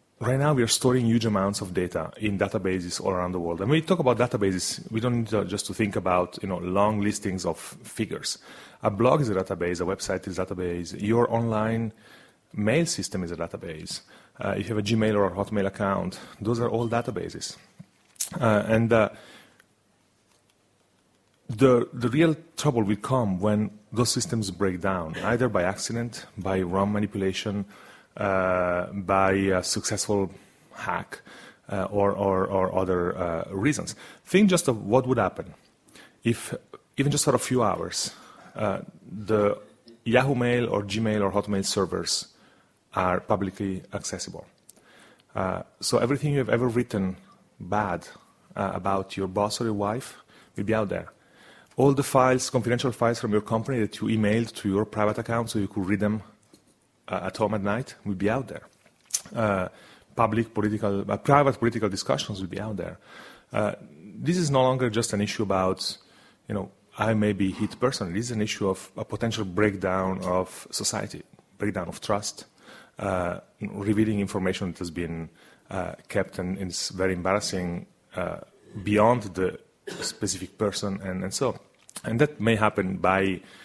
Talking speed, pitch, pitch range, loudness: 170 wpm, 105 Hz, 95-115 Hz, -26 LUFS